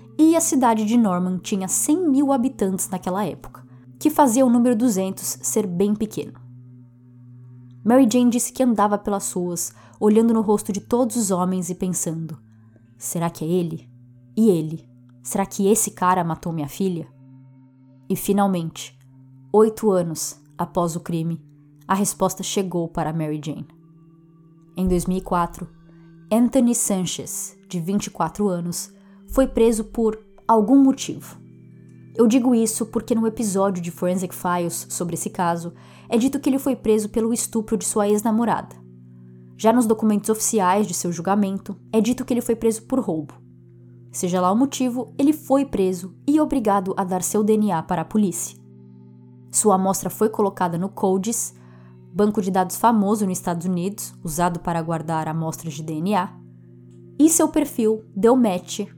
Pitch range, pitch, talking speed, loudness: 160-220 Hz, 185 Hz, 155 wpm, -21 LUFS